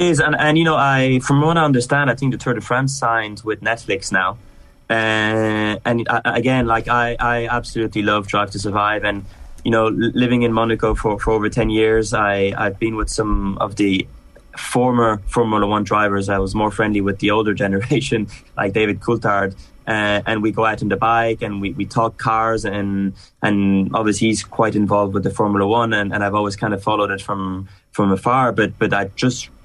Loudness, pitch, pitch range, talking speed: -18 LUFS, 110 Hz, 100-115 Hz, 210 wpm